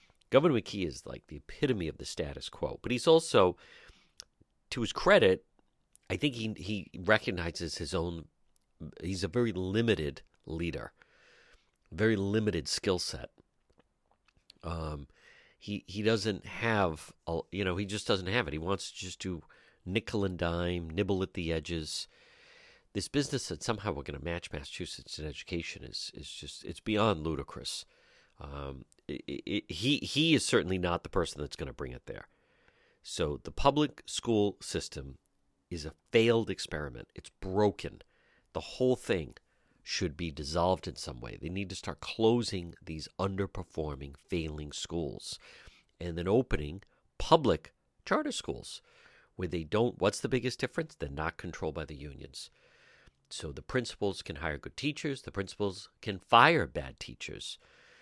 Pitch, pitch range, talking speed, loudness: 95 Hz, 80-110 Hz, 155 wpm, -33 LUFS